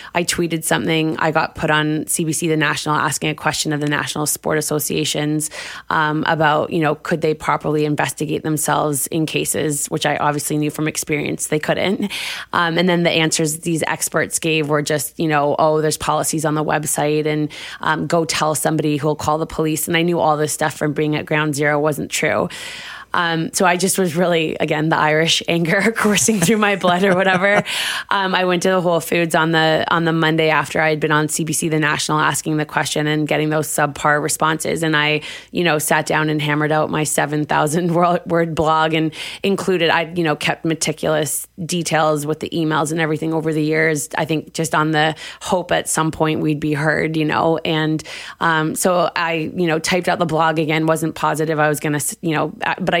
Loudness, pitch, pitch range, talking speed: -18 LUFS, 155 Hz, 150-165 Hz, 210 wpm